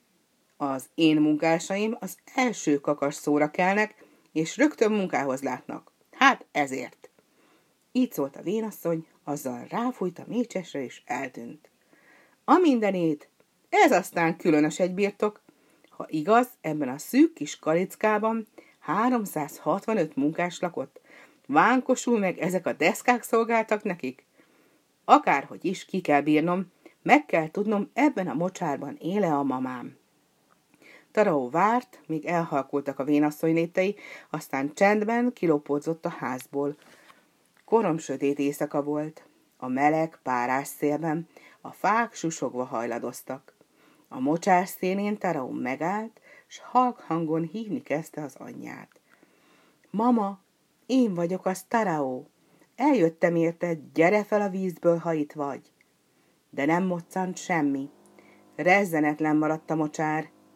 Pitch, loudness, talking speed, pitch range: 175 Hz, -26 LUFS, 120 wpm, 150-215 Hz